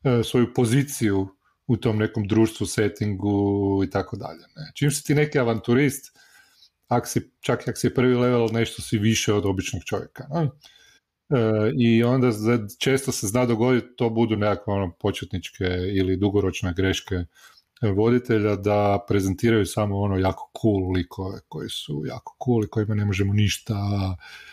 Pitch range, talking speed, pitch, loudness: 100-120 Hz, 155 wpm, 110 Hz, -23 LUFS